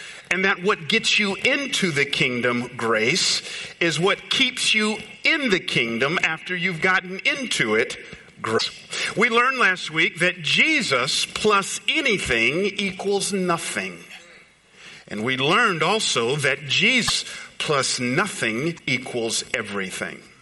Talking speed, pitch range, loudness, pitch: 125 wpm, 155-210 Hz, -21 LUFS, 185 Hz